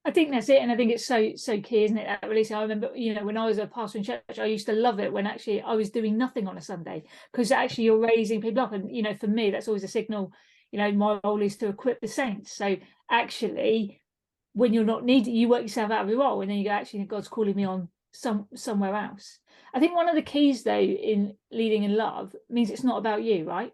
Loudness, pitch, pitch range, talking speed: -26 LUFS, 220 Hz, 210-240 Hz, 270 wpm